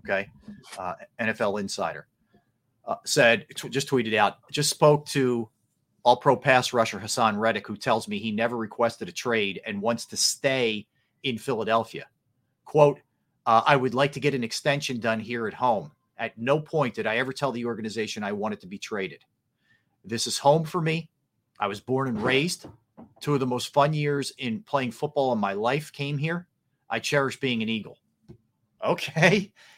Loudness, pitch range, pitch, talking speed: -26 LUFS, 115-145 Hz, 135 Hz, 180 wpm